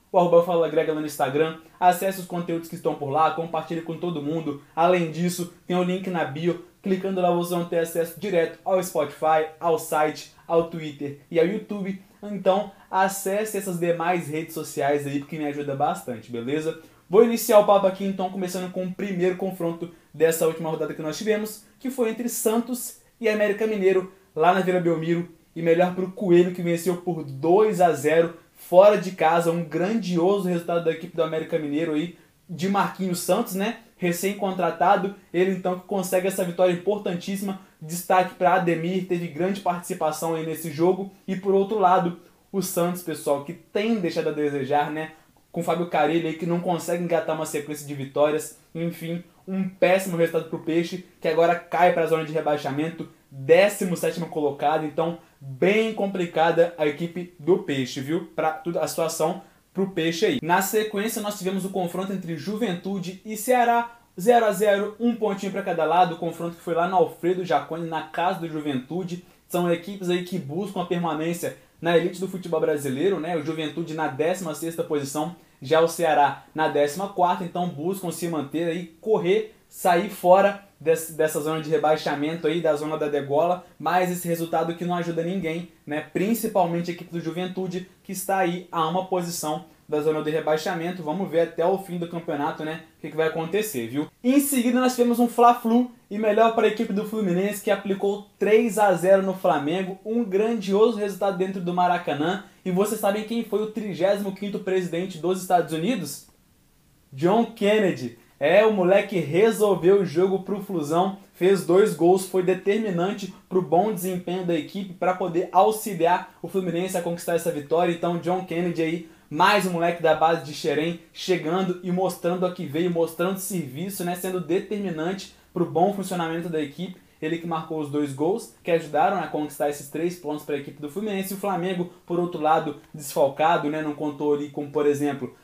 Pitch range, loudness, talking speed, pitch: 160-190 Hz, -24 LUFS, 185 wpm, 175 Hz